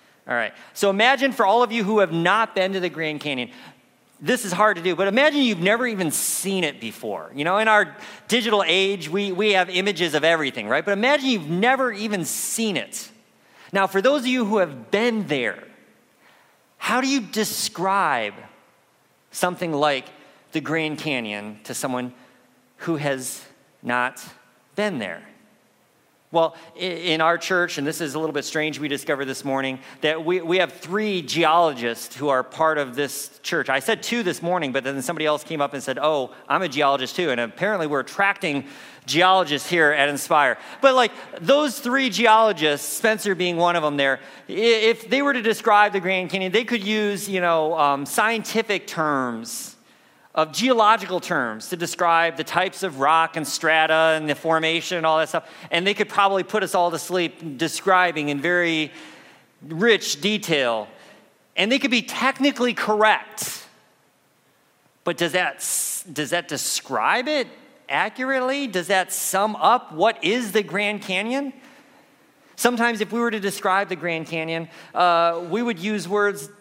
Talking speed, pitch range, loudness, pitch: 175 wpm, 155-215 Hz, -21 LUFS, 180 Hz